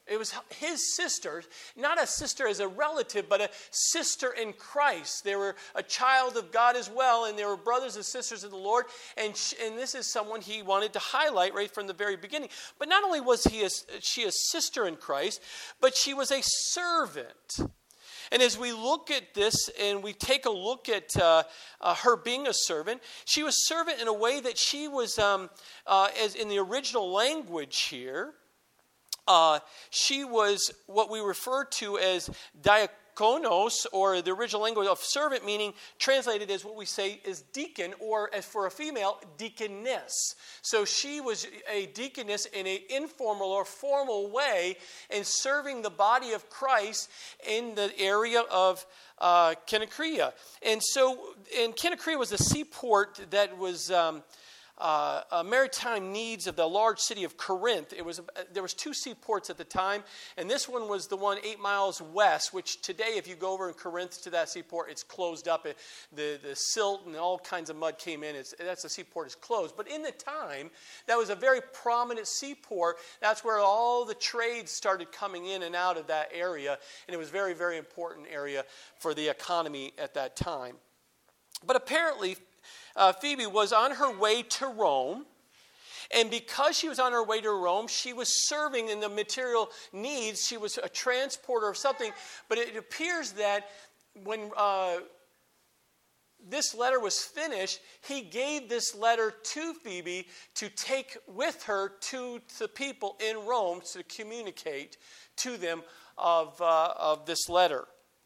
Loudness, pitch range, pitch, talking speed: -30 LUFS, 190-255 Hz, 215 Hz, 180 wpm